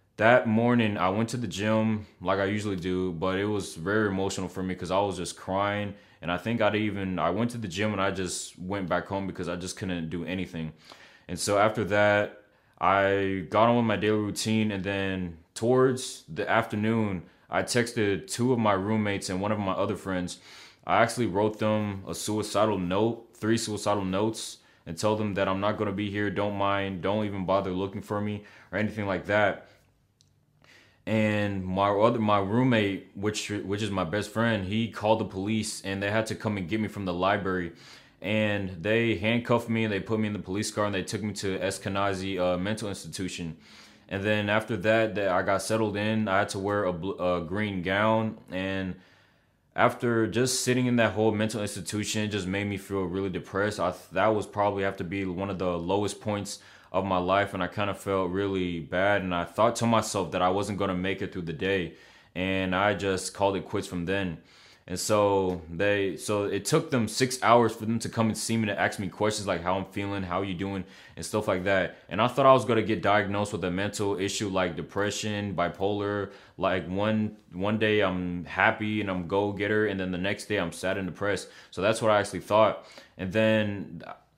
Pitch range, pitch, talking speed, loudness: 95-110 Hz, 100 Hz, 220 wpm, -28 LUFS